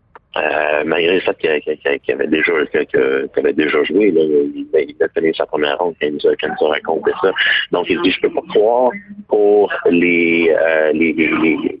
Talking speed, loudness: 210 wpm, -15 LUFS